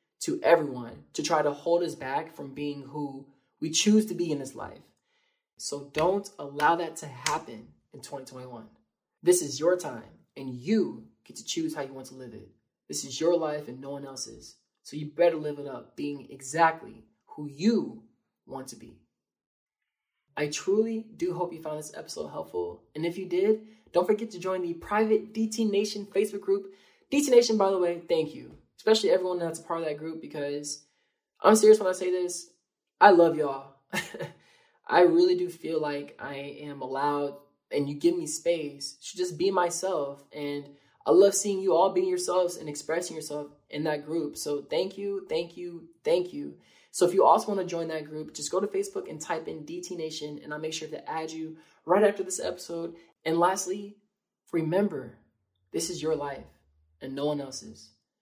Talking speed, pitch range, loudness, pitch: 195 wpm, 145-195 Hz, -28 LUFS, 165 Hz